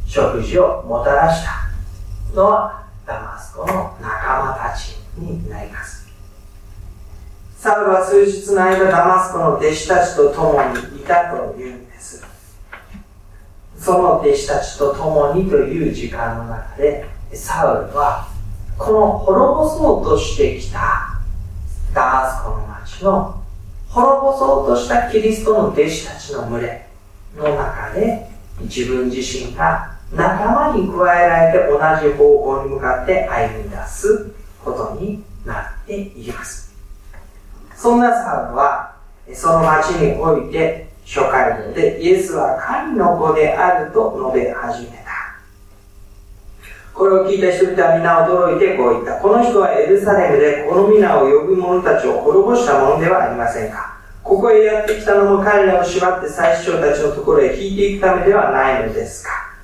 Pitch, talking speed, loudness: 155 Hz, 275 characters per minute, -15 LUFS